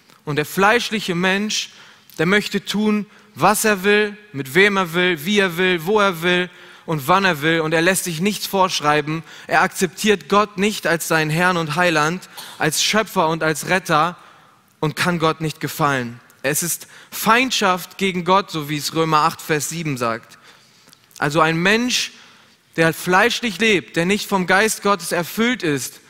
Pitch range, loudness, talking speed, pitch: 160-200 Hz, -18 LUFS, 170 wpm, 180 Hz